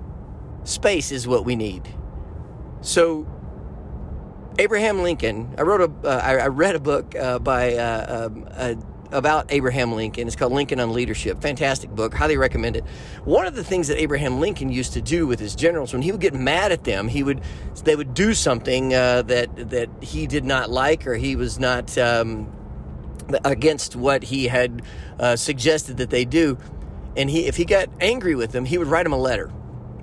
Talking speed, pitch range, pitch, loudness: 190 wpm, 115-145 Hz, 125 Hz, -21 LUFS